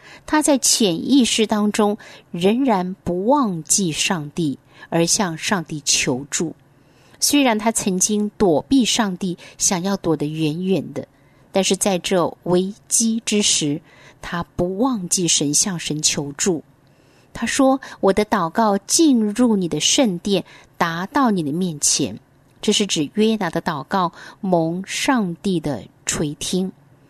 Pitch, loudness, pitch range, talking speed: 185 Hz, -19 LUFS, 160-215 Hz, 190 characters per minute